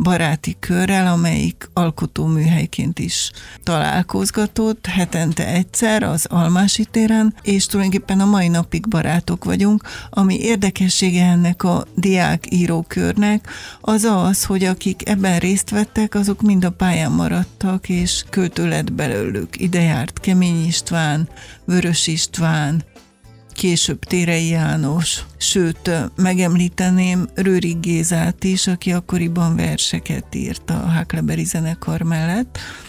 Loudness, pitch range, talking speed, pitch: -18 LUFS, 165-195 Hz, 110 wpm, 180 Hz